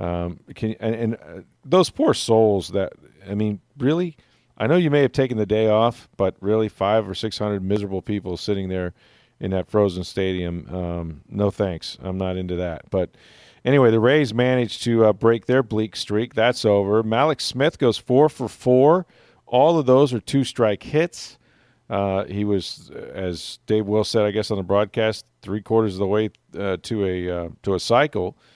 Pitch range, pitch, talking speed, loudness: 95-120 Hz, 105 Hz, 190 wpm, -21 LUFS